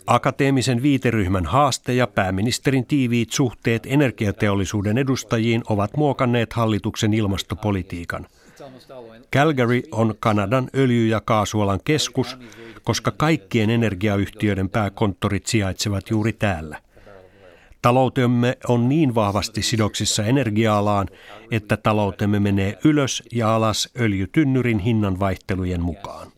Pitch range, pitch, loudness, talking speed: 105-125 Hz, 115 Hz, -21 LUFS, 100 wpm